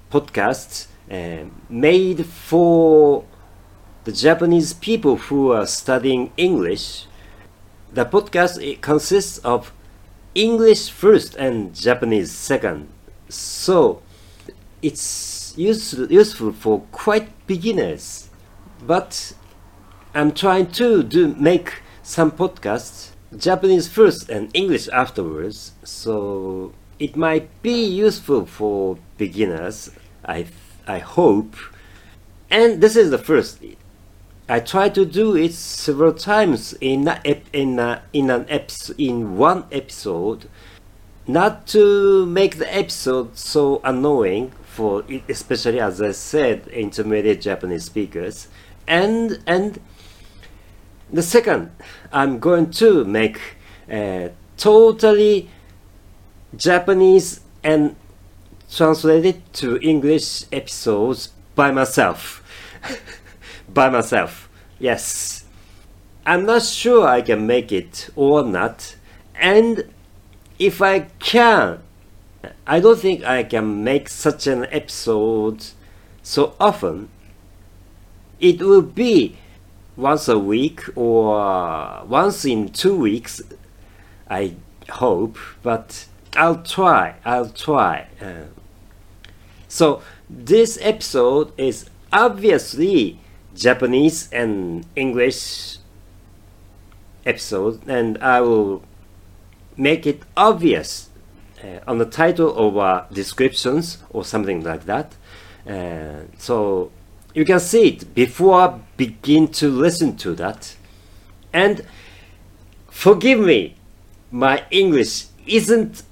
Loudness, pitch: -18 LUFS, 110 Hz